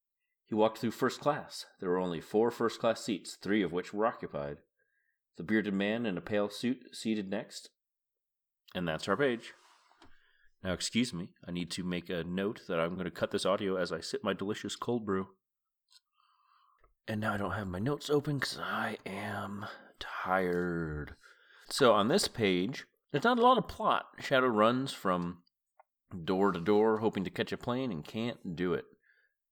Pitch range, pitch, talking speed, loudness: 90-130 Hz, 105 Hz, 185 wpm, -33 LUFS